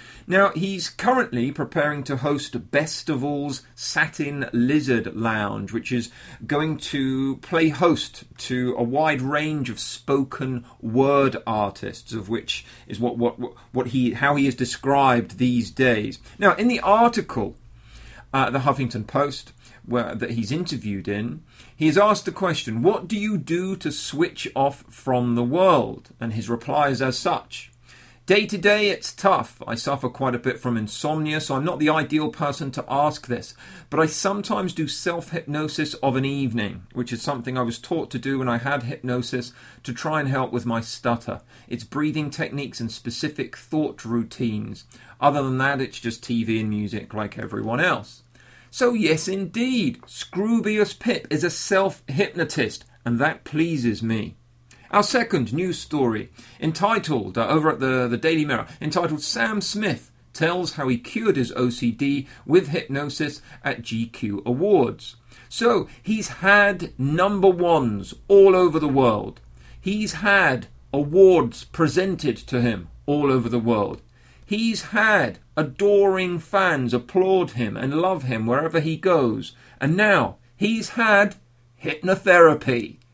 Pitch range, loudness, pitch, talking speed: 120-165 Hz, -22 LUFS, 140 Hz, 155 wpm